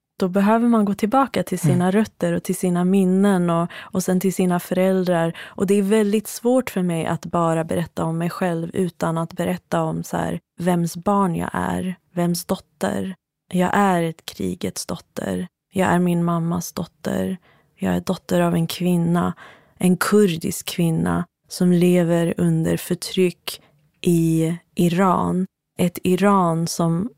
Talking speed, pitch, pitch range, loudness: 155 wpm, 175 Hz, 165-190 Hz, -21 LUFS